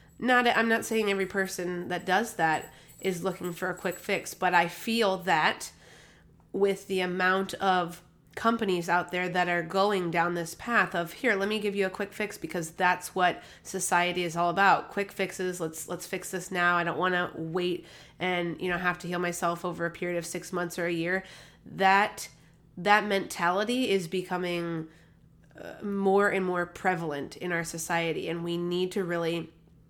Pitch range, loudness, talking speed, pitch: 170-195 Hz, -28 LUFS, 185 wpm, 180 Hz